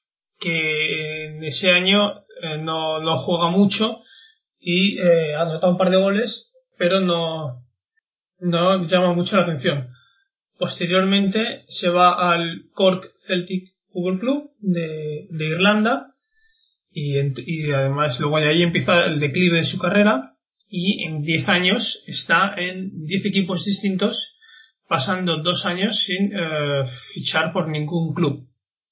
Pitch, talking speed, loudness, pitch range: 180 Hz, 135 wpm, -20 LUFS, 160-200 Hz